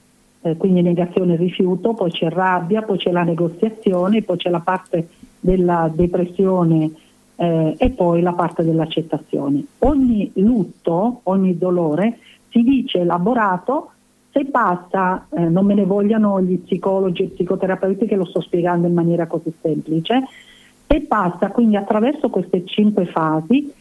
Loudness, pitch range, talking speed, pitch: -18 LUFS, 175-220 Hz, 145 wpm, 185 Hz